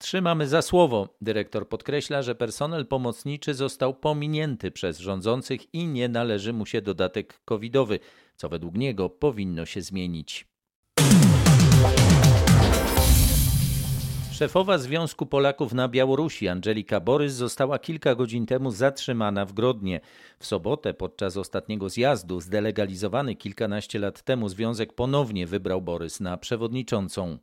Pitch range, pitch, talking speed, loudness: 100-135 Hz, 120 Hz, 120 wpm, -24 LUFS